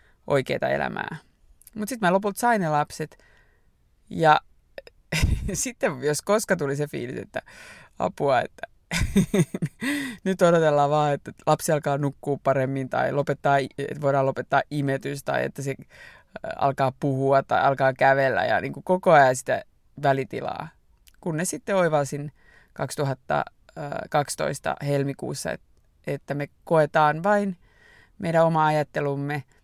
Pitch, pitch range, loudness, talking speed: 145 Hz, 140-175 Hz, -24 LUFS, 120 wpm